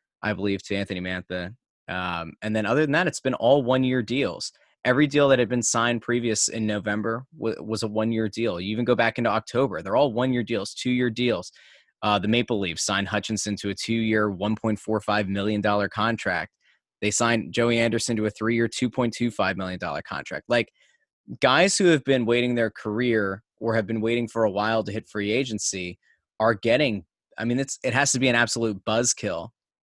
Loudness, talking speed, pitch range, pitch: -24 LUFS, 205 wpm, 105-120 Hz, 115 Hz